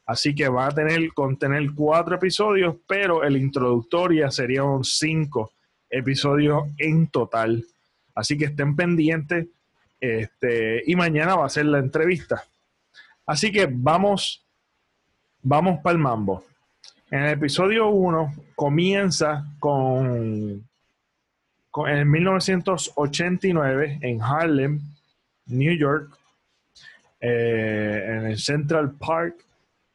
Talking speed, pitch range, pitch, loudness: 110 wpm, 130-165 Hz, 150 Hz, -22 LUFS